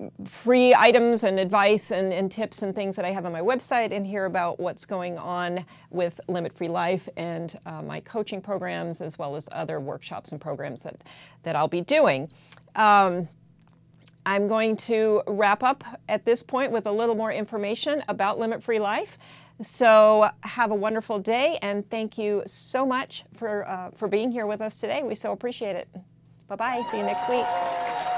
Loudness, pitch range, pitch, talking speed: -25 LUFS, 175-225 Hz, 205 Hz, 185 wpm